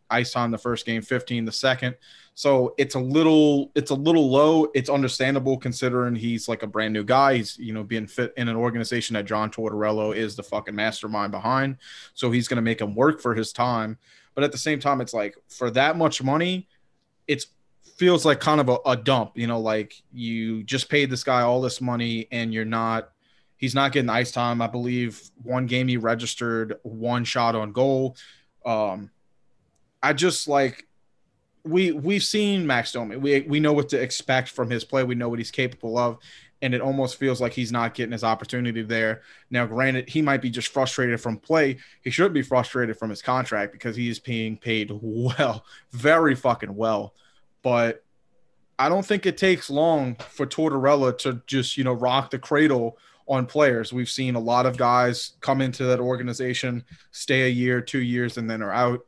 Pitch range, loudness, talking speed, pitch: 115-135 Hz, -24 LUFS, 200 wpm, 125 Hz